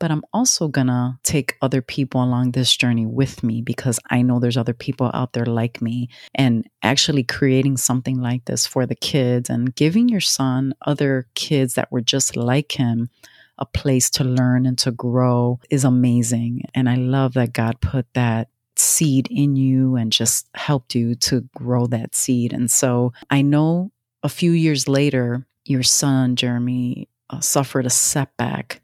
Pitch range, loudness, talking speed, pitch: 120-135 Hz, -19 LUFS, 175 wpm, 125 Hz